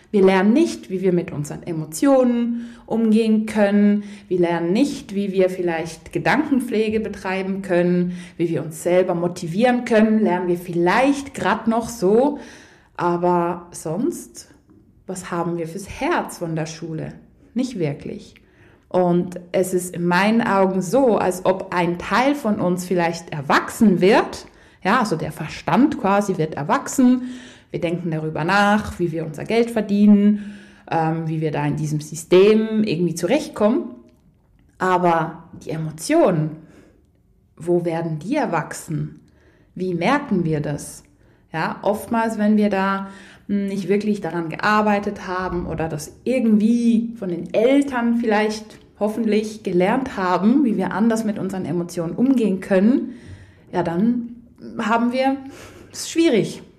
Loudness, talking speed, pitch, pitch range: -20 LUFS, 135 wpm, 190 Hz, 170-225 Hz